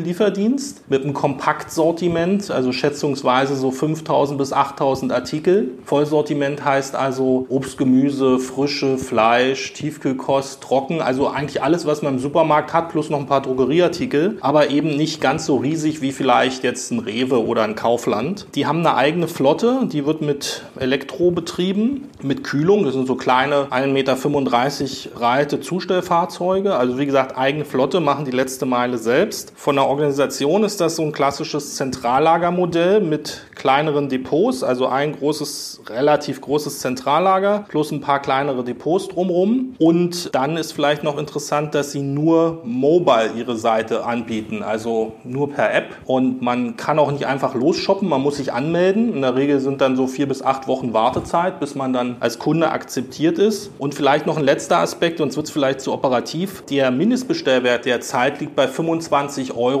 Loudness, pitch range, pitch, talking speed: -19 LUFS, 130-165 Hz, 145 Hz, 170 wpm